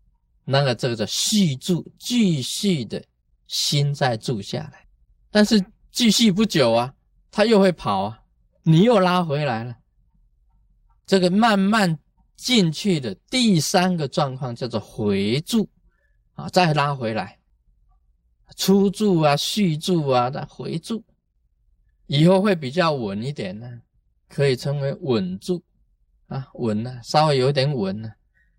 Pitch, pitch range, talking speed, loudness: 155 Hz, 120-190 Hz, 190 characters per minute, -21 LUFS